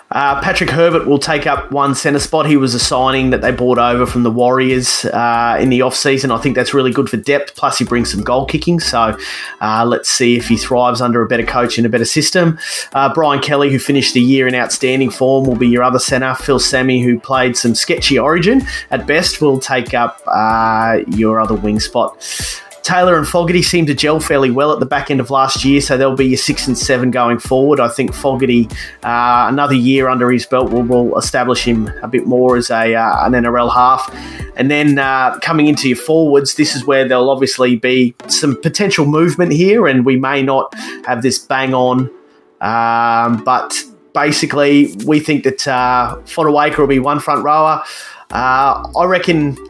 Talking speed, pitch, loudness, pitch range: 205 wpm, 130 Hz, -13 LUFS, 125-145 Hz